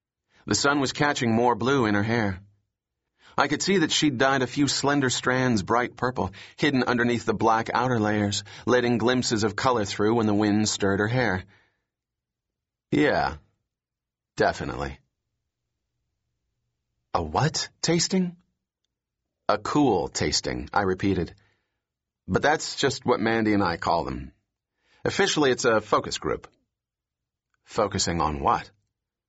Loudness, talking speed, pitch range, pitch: -24 LUFS, 135 wpm, 100-125 Hz, 115 Hz